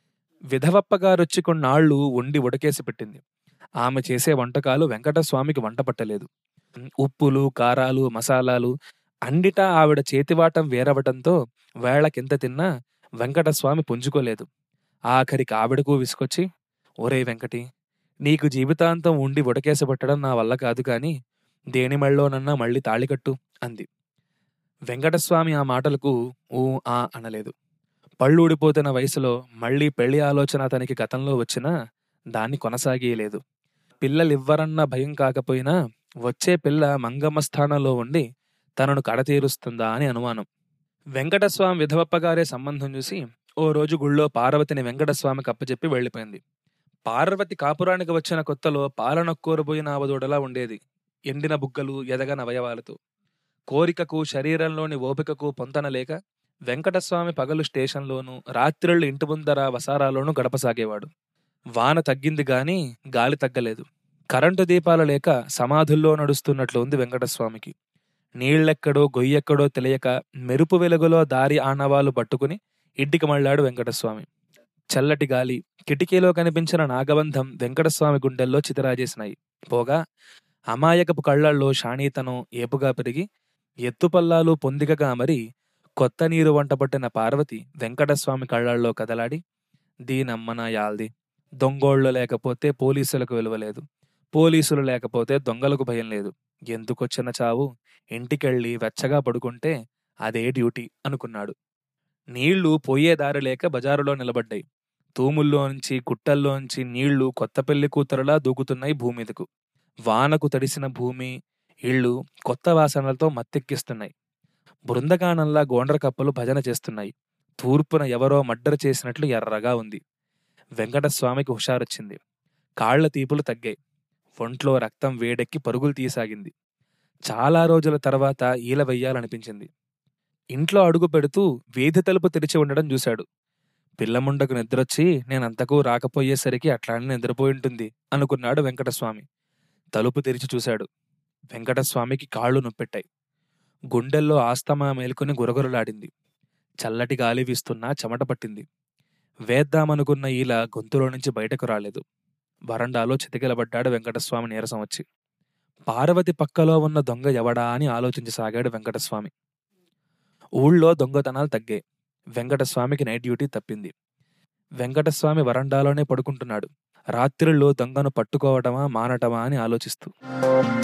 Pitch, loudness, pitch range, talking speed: 140 Hz, -22 LUFS, 125-155 Hz, 100 wpm